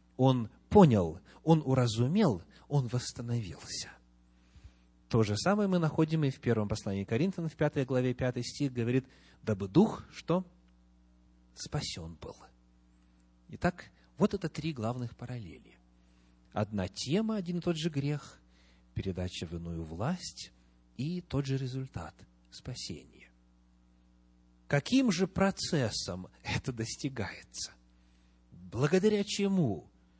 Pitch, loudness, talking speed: 110 Hz, -32 LUFS, 110 wpm